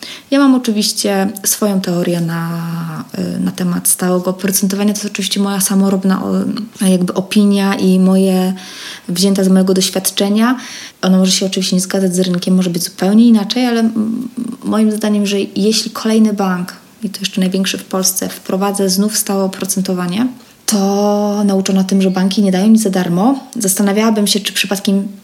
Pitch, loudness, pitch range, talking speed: 195 Hz, -14 LUFS, 190-210 Hz, 155 wpm